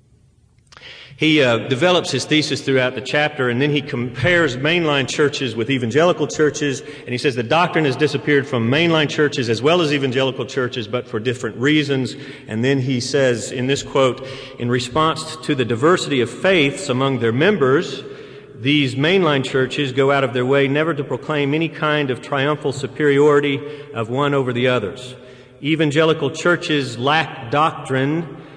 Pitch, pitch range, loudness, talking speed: 140 Hz, 130-150 Hz, -18 LUFS, 165 wpm